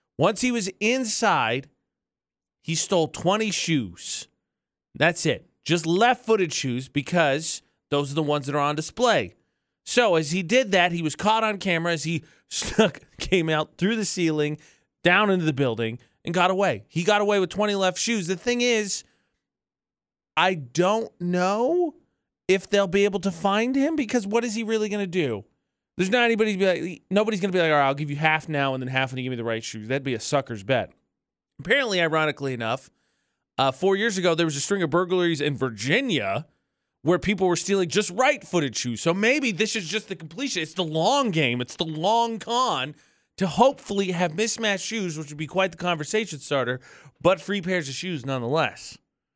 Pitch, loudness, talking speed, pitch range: 180 Hz, -24 LUFS, 200 wpm, 150-210 Hz